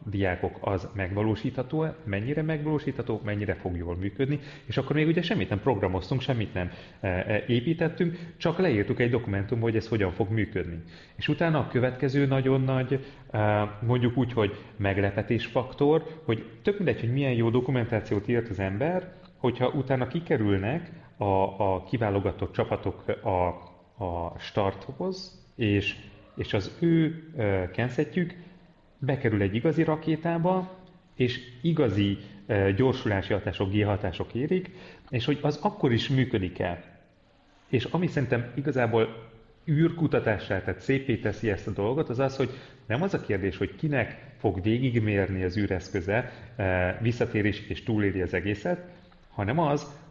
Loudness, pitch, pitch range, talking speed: -28 LUFS, 120 Hz, 100-145 Hz, 135 wpm